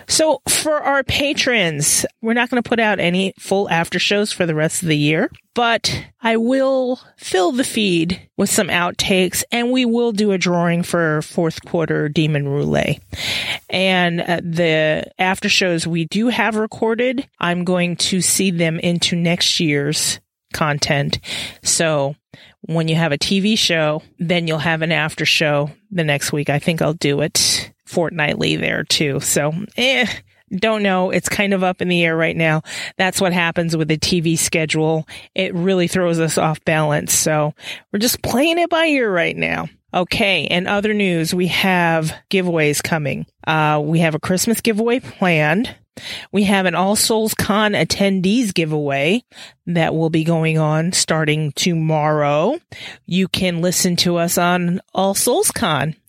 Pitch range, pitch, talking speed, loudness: 160-205 Hz, 175 Hz, 165 wpm, -17 LUFS